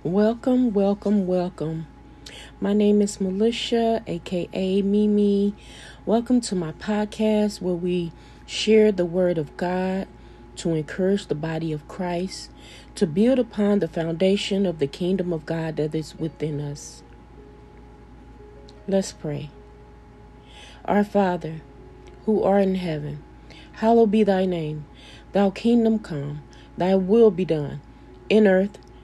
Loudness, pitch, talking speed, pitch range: -23 LUFS, 185 Hz, 125 wpm, 155-205 Hz